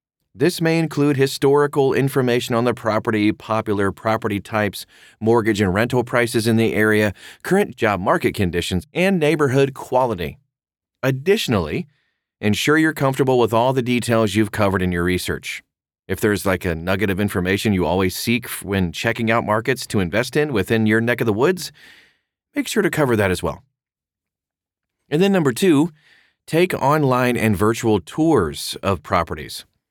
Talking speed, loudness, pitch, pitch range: 160 wpm, -19 LUFS, 115 Hz, 100-135 Hz